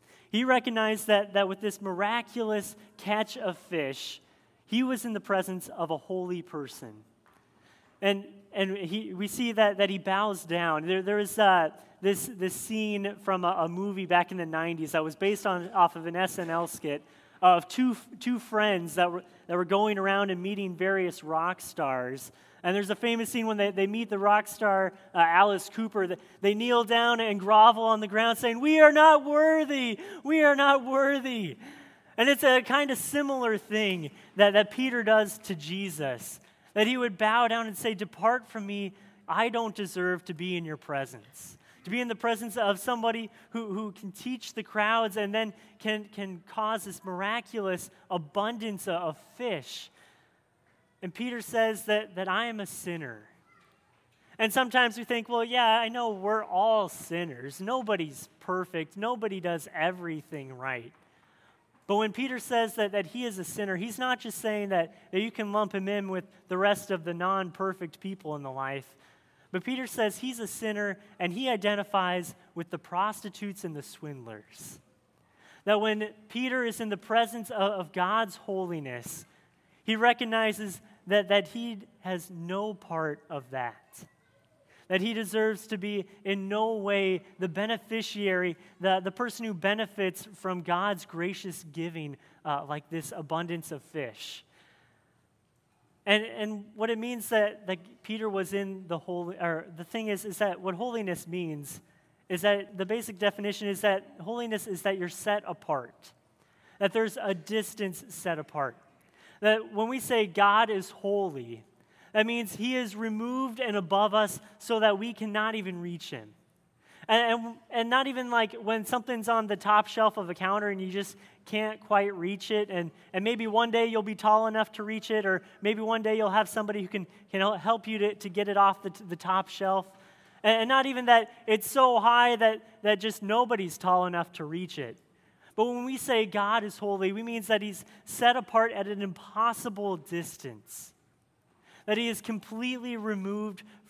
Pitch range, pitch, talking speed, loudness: 185-225 Hz, 205 Hz, 180 wpm, -28 LUFS